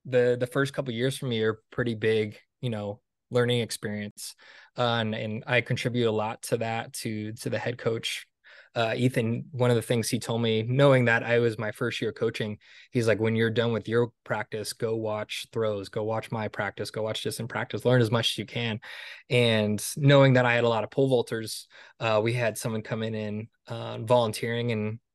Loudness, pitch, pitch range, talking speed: -27 LUFS, 115 Hz, 110-125 Hz, 220 wpm